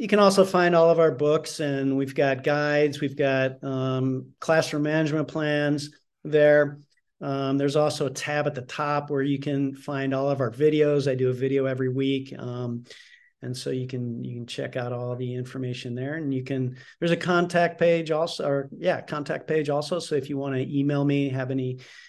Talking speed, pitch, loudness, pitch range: 205 wpm, 140 Hz, -25 LUFS, 130-155 Hz